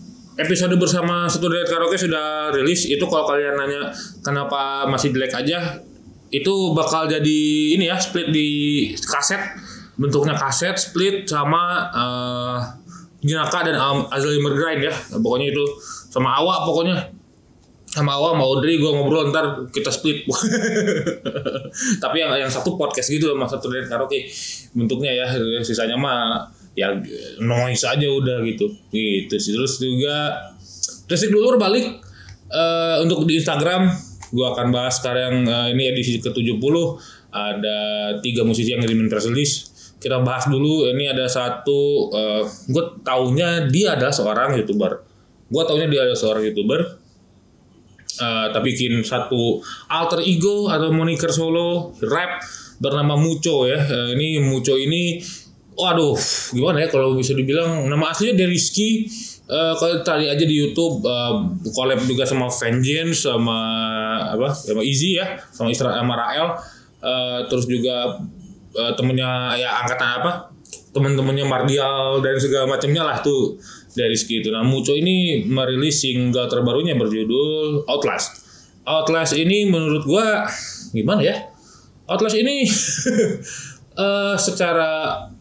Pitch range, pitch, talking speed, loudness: 125-170 Hz, 140 Hz, 130 wpm, -20 LUFS